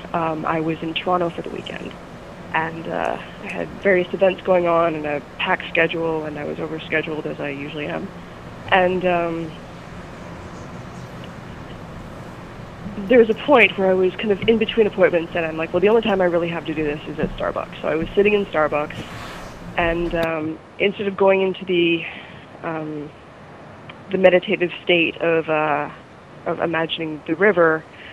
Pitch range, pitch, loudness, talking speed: 155-185 Hz, 165 Hz, -20 LUFS, 175 wpm